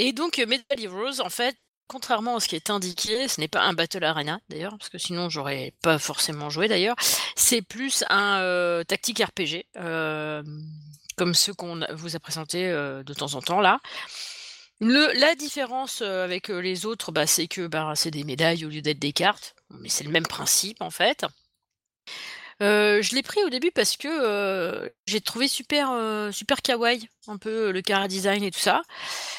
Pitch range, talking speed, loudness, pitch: 165-240 Hz, 190 wpm, -24 LUFS, 195 Hz